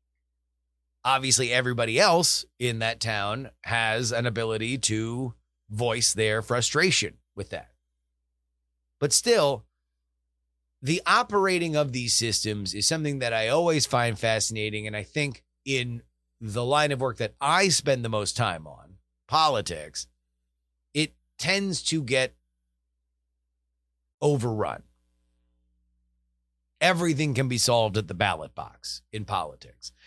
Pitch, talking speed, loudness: 110 Hz, 120 wpm, -25 LUFS